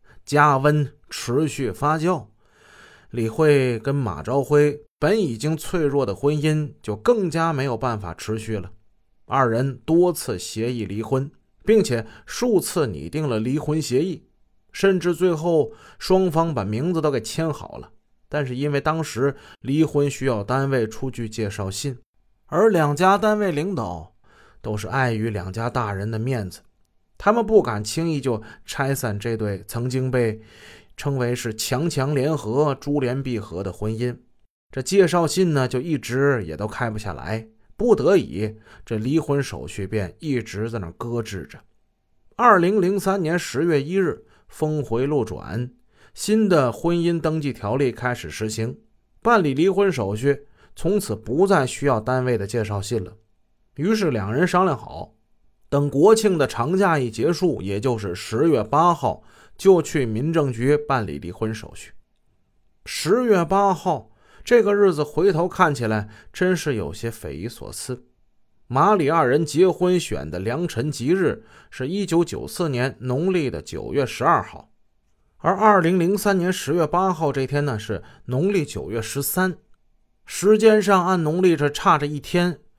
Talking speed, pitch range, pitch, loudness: 225 characters per minute, 110-165 Hz, 135 Hz, -22 LUFS